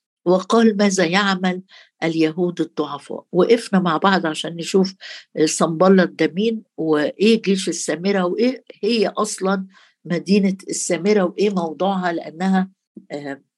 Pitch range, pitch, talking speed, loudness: 165-200 Hz, 185 Hz, 105 wpm, -19 LUFS